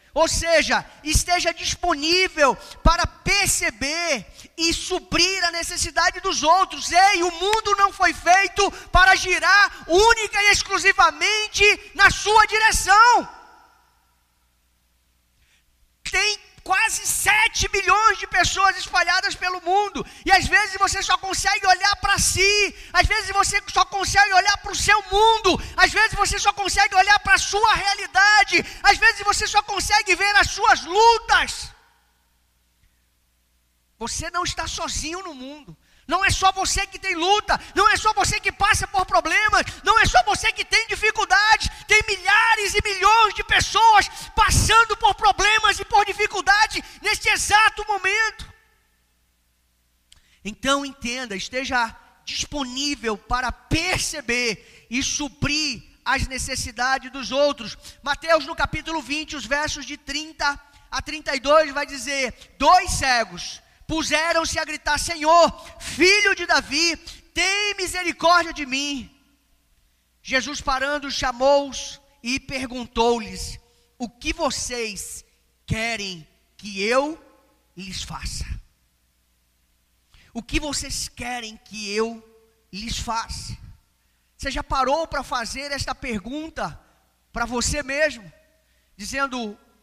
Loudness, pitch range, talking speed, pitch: -19 LUFS, 260-395 Hz, 125 wpm, 335 Hz